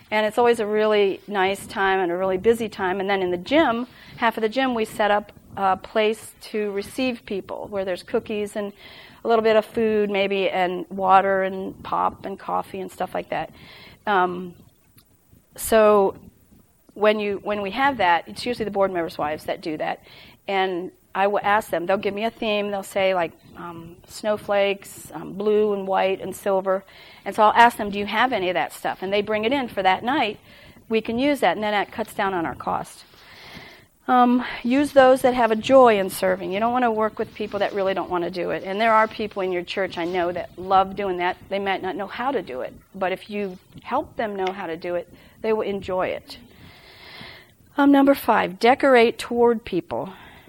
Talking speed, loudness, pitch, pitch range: 215 wpm, -22 LUFS, 205 Hz, 190-225 Hz